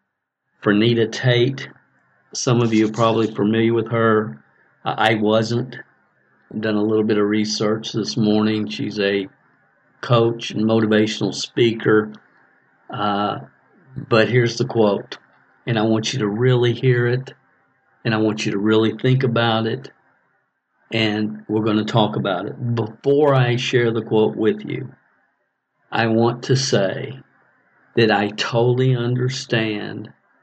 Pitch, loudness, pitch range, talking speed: 110 Hz, -19 LUFS, 105-120 Hz, 140 wpm